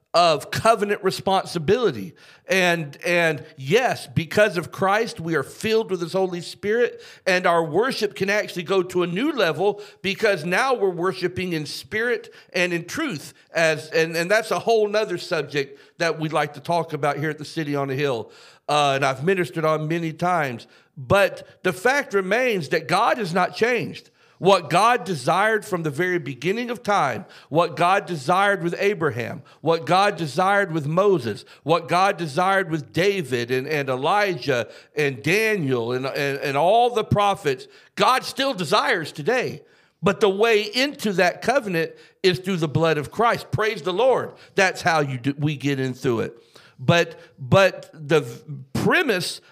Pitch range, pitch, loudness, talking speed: 155-200 Hz, 175 Hz, -22 LUFS, 170 wpm